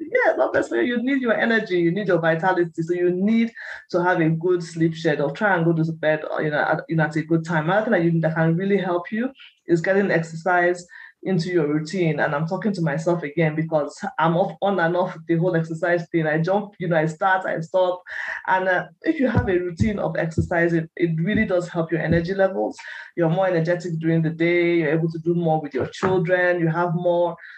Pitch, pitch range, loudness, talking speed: 175 Hz, 165-185 Hz, -22 LUFS, 230 wpm